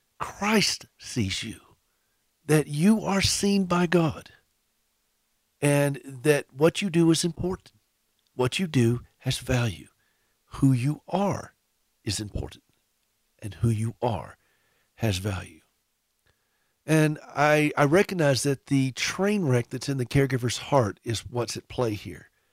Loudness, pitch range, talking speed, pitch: -25 LUFS, 115-150 Hz, 135 wpm, 130 Hz